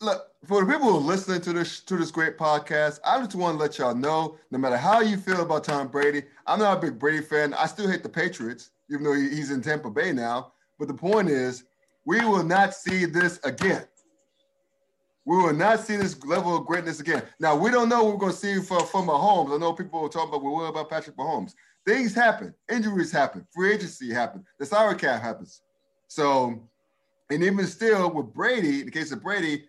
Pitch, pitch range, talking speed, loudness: 175 Hz, 150-200 Hz, 220 wpm, -25 LUFS